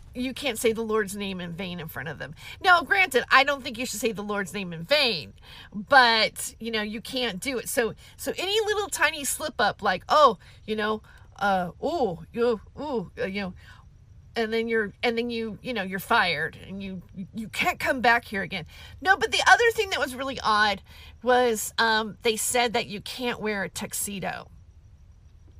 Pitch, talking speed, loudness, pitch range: 225 Hz, 205 wpm, -25 LUFS, 195-255 Hz